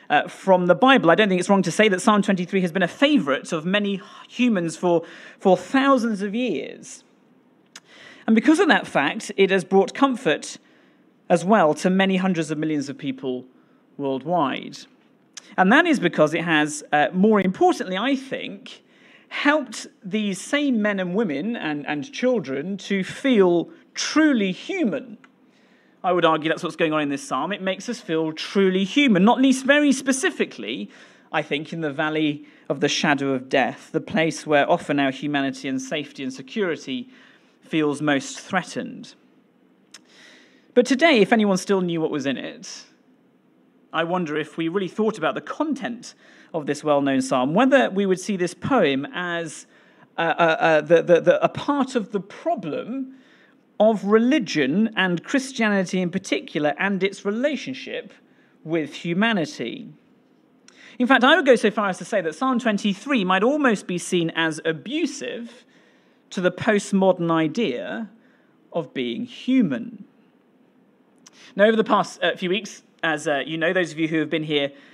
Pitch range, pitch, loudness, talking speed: 165-245 Hz, 195 Hz, -21 LUFS, 165 wpm